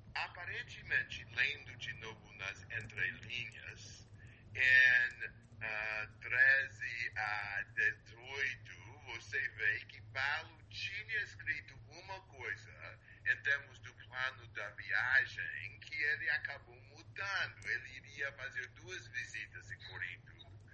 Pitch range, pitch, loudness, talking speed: 105-115 Hz, 110 Hz, -36 LUFS, 105 wpm